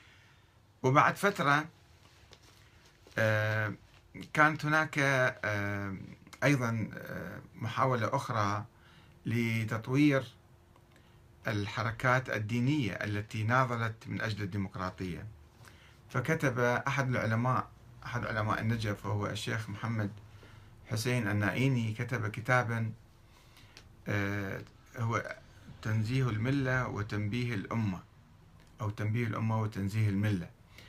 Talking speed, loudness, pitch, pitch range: 75 wpm, -32 LUFS, 110 Hz, 105-125 Hz